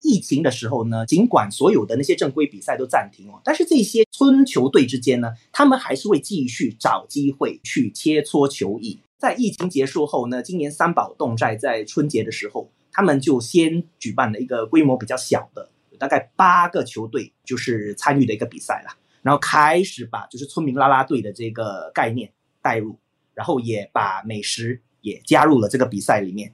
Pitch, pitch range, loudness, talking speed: 130 Hz, 115-175 Hz, -20 LUFS, 300 characters per minute